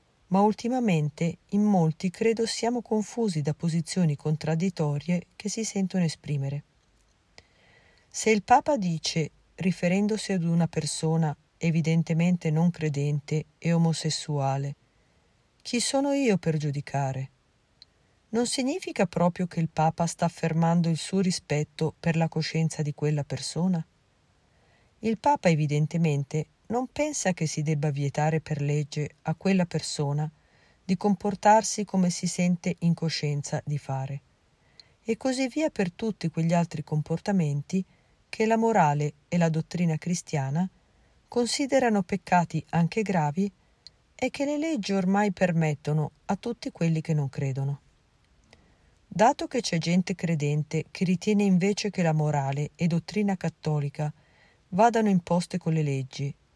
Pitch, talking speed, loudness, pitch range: 170 Hz, 130 wpm, -27 LUFS, 155-200 Hz